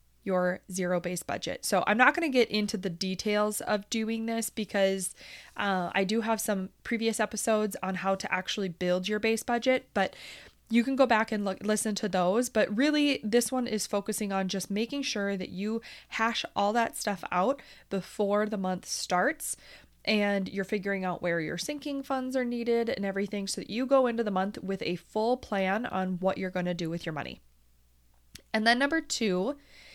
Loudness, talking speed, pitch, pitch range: -29 LUFS, 200 wpm, 210 Hz, 190-230 Hz